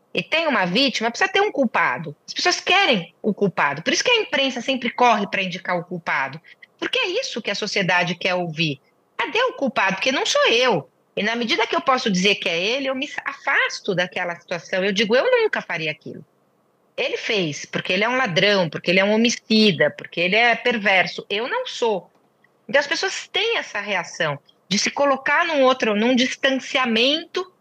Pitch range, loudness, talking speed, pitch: 190-290 Hz, -20 LUFS, 200 wpm, 235 Hz